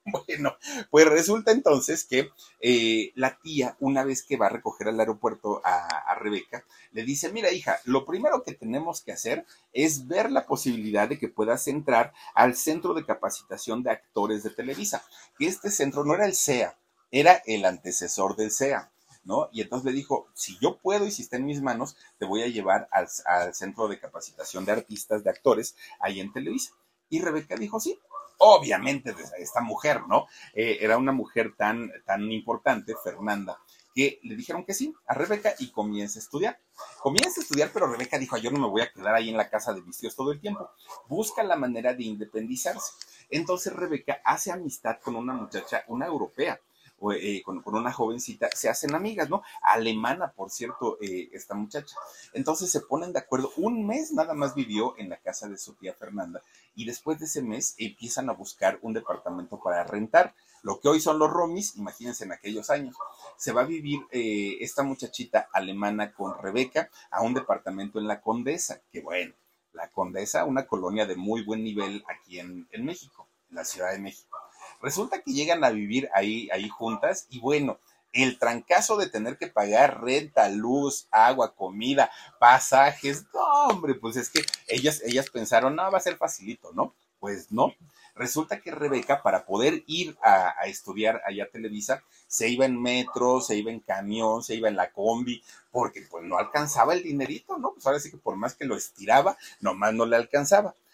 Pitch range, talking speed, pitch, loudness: 110-160 Hz, 190 wpm, 130 Hz, -27 LUFS